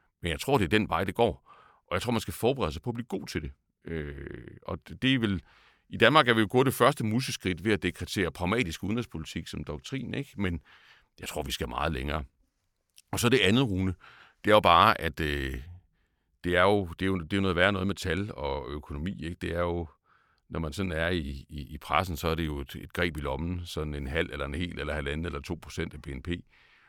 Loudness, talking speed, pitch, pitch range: -29 LUFS, 245 wpm, 85 Hz, 75-100 Hz